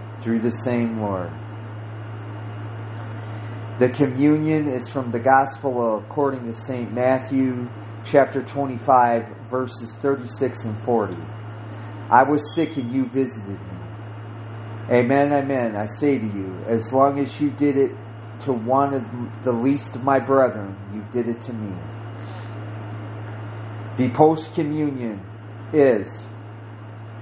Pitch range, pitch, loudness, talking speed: 110-130 Hz, 115 Hz, -22 LUFS, 125 wpm